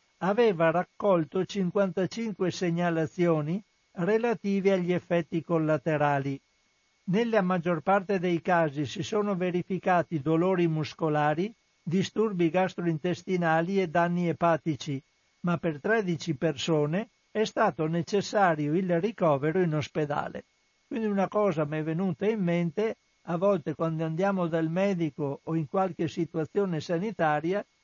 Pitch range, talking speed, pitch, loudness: 160-195 Hz, 115 wpm, 175 Hz, -28 LUFS